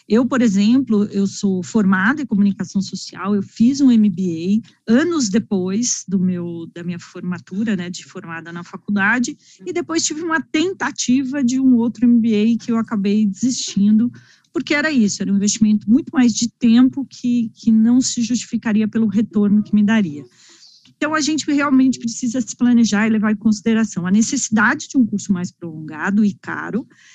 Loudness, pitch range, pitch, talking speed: -17 LUFS, 200-245 Hz, 225 Hz, 170 wpm